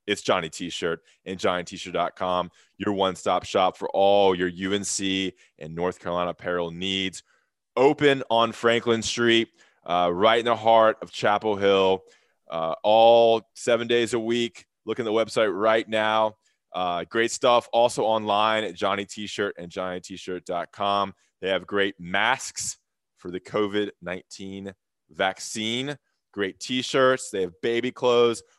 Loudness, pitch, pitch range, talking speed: -24 LUFS, 105 Hz, 95-115 Hz, 155 wpm